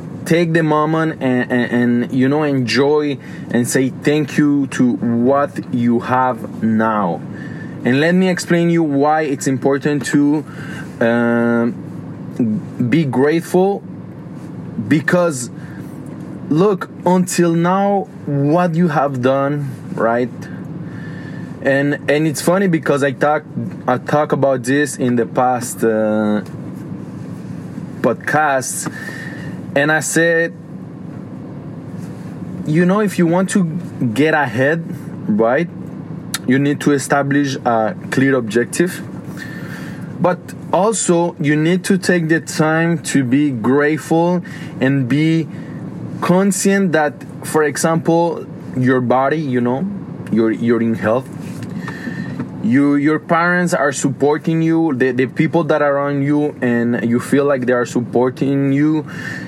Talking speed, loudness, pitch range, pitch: 120 wpm, -16 LUFS, 130-165 Hz, 150 Hz